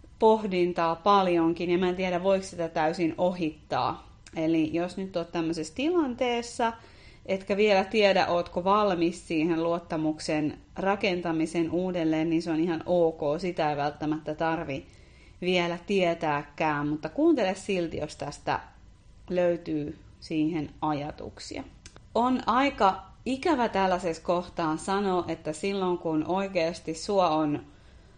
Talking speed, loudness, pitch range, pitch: 120 wpm, -27 LUFS, 160-195 Hz, 175 Hz